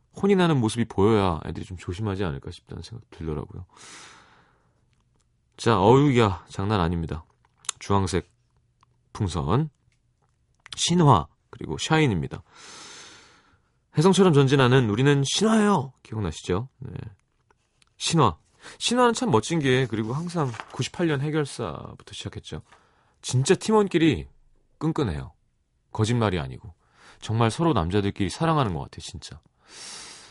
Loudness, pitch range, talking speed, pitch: -23 LUFS, 105-160 Hz, 275 characters per minute, 130 Hz